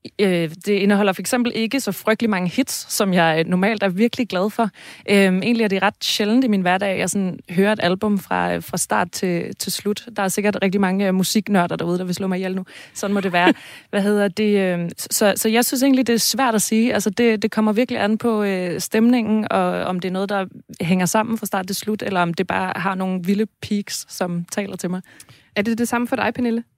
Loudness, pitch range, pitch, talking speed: -20 LUFS, 185-220 Hz, 200 Hz, 230 wpm